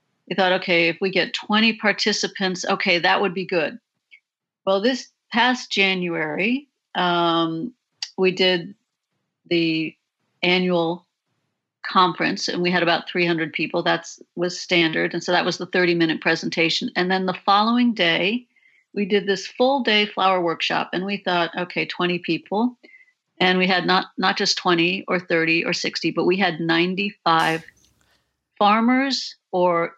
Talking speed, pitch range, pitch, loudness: 155 wpm, 175-205 Hz, 185 Hz, -21 LUFS